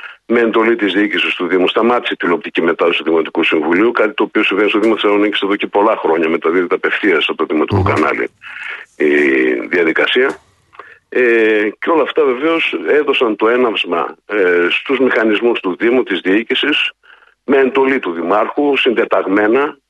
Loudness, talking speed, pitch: -14 LUFS, 160 wpm, 145 Hz